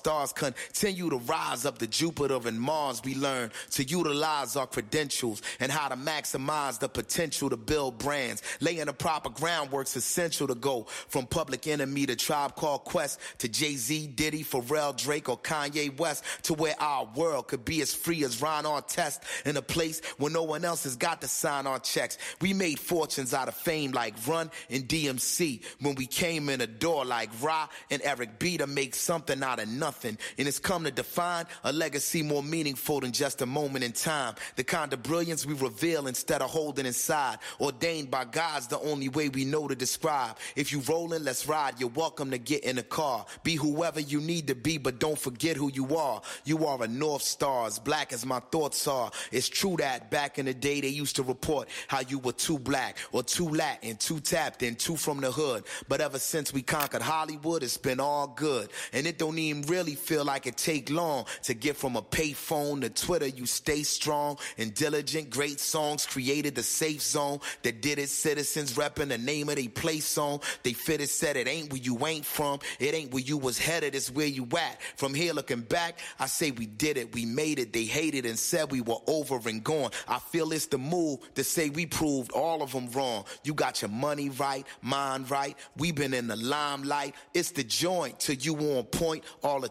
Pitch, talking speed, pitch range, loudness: 145 Hz, 215 wpm, 135-160 Hz, -30 LUFS